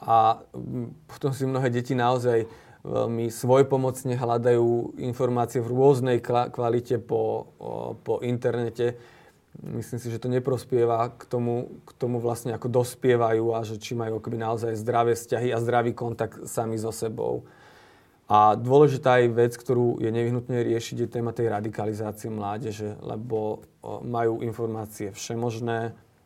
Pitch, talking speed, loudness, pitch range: 120 Hz, 135 wpm, -26 LUFS, 115-125 Hz